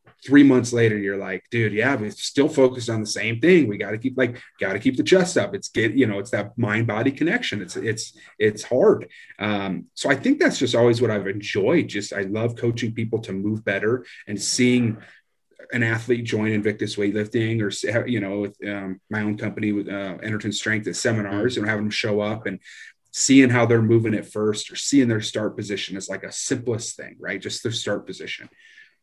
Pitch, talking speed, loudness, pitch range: 110 Hz, 215 wpm, -22 LUFS, 105-125 Hz